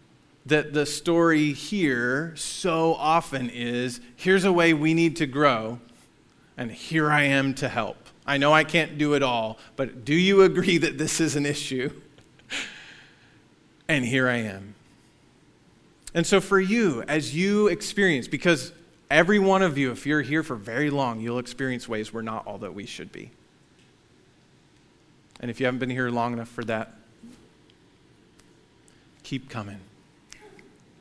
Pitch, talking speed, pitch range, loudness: 145 Hz, 155 wpm, 120-165 Hz, -24 LUFS